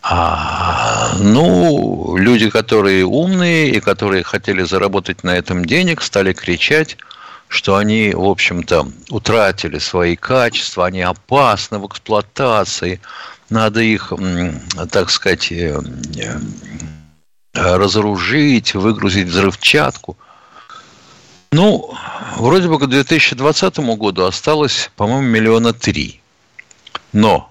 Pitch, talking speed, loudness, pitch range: 105 Hz, 95 wpm, -14 LUFS, 90-130 Hz